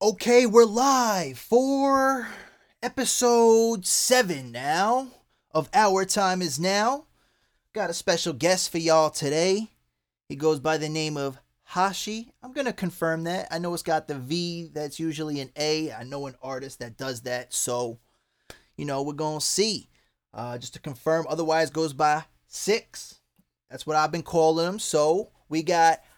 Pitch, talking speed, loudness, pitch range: 160 Hz, 160 wpm, -24 LUFS, 150-205 Hz